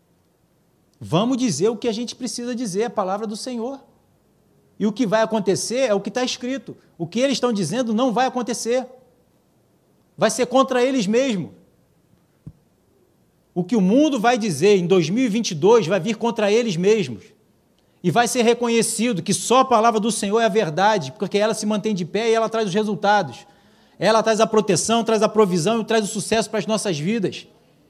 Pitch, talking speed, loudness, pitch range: 220 Hz, 185 wpm, -20 LUFS, 205-240 Hz